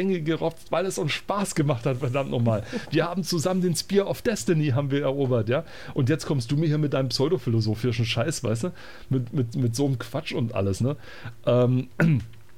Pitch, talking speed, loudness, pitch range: 135 Hz, 200 wpm, -25 LUFS, 125-165 Hz